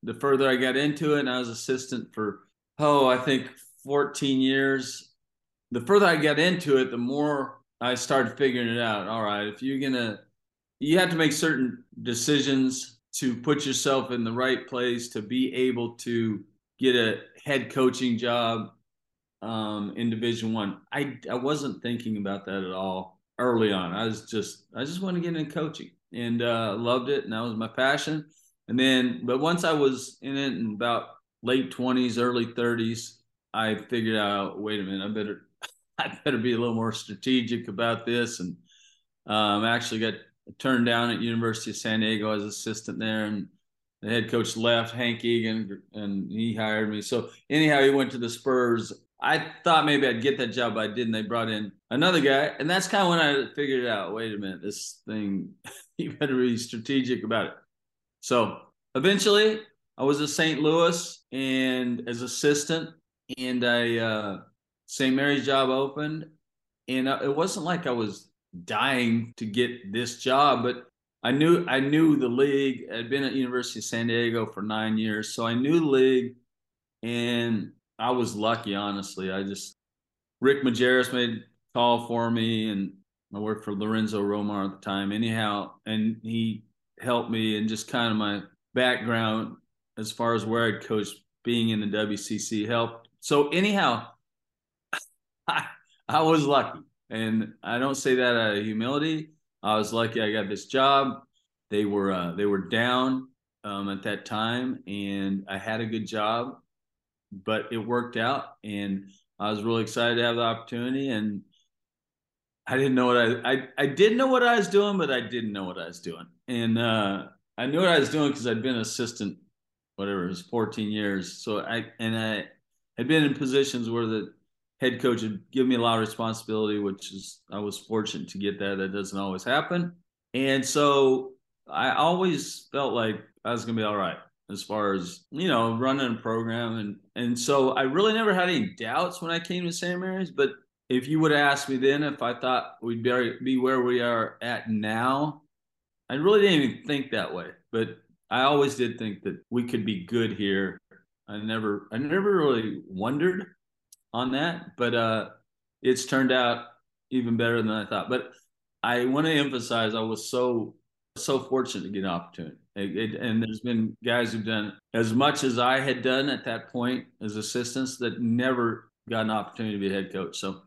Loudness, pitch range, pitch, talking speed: -26 LUFS, 110-135 Hz, 120 Hz, 185 wpm